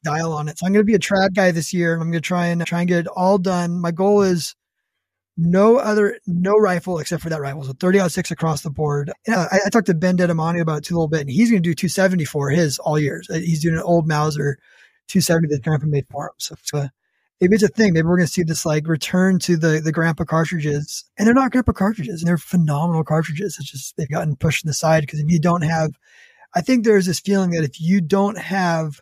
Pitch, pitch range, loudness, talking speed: 170 Hz, 155-190 Hz, -19 LUFS, 265 wpm